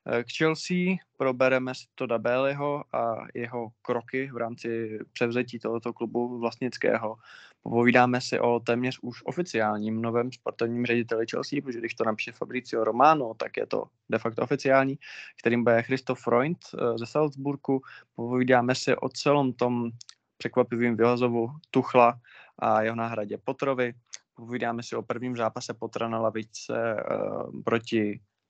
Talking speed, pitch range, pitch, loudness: 135 wpm, 115-130 Hz, 120 Hz, -27 LUFS